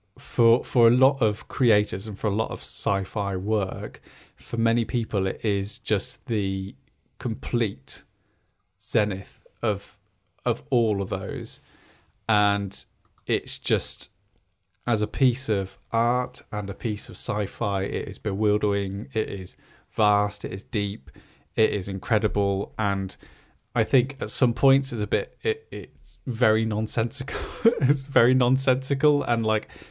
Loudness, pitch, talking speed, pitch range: -25 LUFS, 105 Hz, 145 wpm, 100-120 Hz